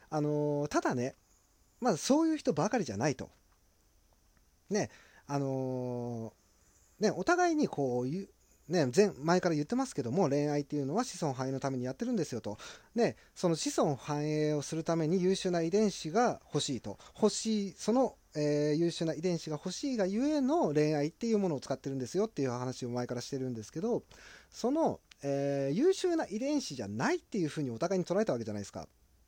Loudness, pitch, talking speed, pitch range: -33 LUFS, 155 Hz, 385 characters per minute, 135-205 Hz